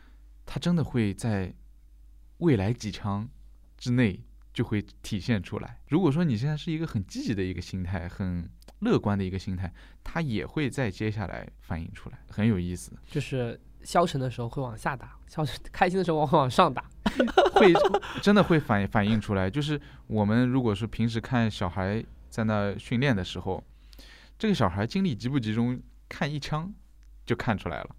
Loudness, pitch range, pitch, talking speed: -28 LUFS, 95-140 Hz, 110 Hz, 265 characters per minute